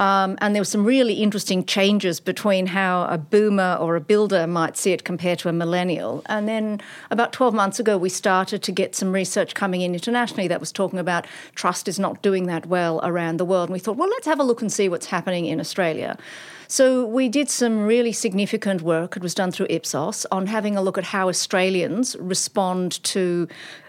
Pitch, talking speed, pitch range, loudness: 190 Hz, 215 wpm, 180-210 Hz, -22 LUFS